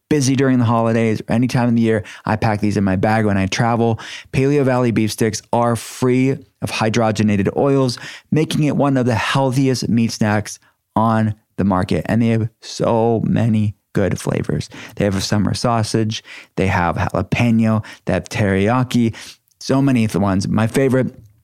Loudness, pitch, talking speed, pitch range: -18 LUFS, 115 Hz, 180 wpm, 105-125 Hz